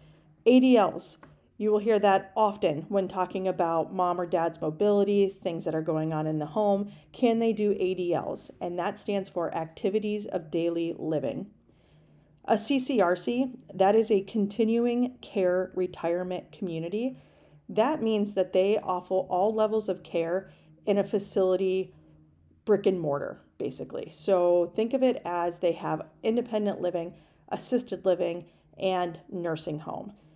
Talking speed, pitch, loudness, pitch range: 140 wpm, 185 Hz, -28 LUFS, 170-210 Hz